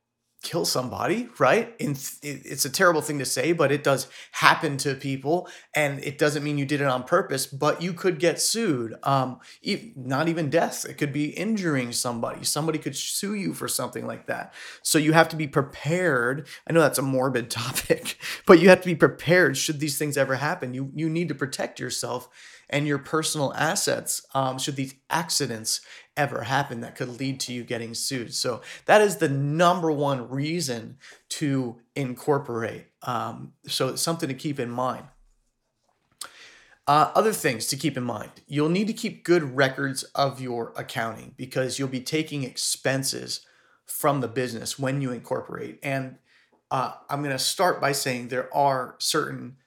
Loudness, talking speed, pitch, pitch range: -25 LUFS, 175 wpm, 140 Hz, 130-160 Hz